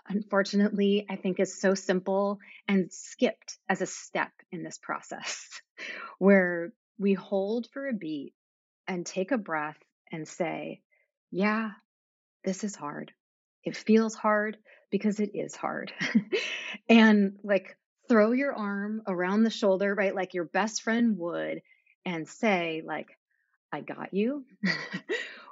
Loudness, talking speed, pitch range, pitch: -29 LUFS, 135 wpm, 190-220 Hz, 200 Hz